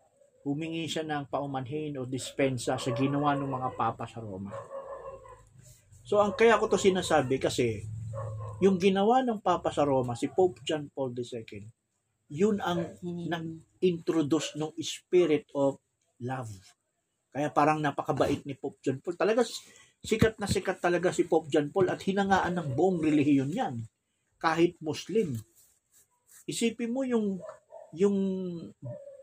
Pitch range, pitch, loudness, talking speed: 130-190 Hz, 155 Hz, -29 LUFS, 135 wpm